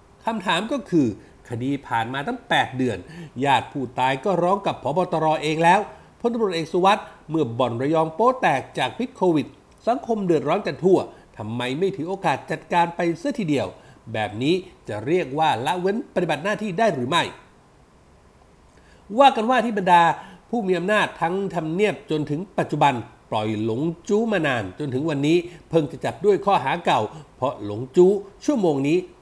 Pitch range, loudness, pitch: 140-200 Hz, -22 LUFS, 170 Hz